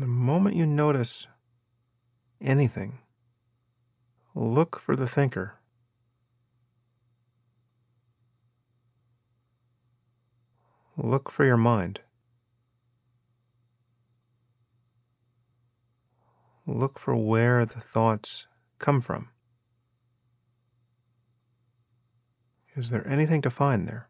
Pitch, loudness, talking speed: 120 Hz, -26 LUFS, 65 wpm